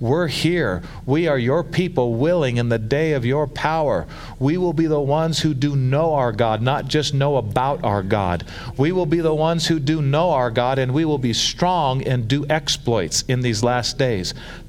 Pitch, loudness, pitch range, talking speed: 140 Hz, -20 LUFS, 125-155 Hz, 210 wpm